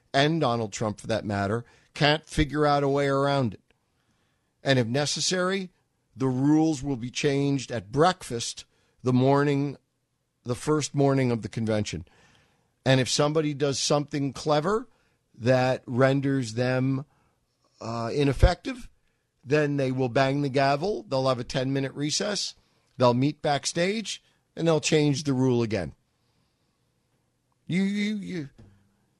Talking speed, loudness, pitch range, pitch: 135 wpm, -26 LUFS, 125-150 Hz, 135 Hz